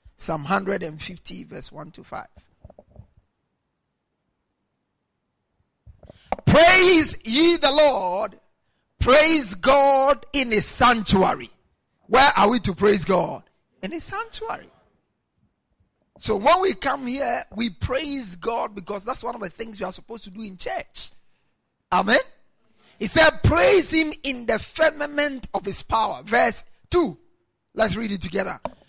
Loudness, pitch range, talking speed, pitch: -20 LUFS, 205-305 Hz, 130 wpm, 250 Hz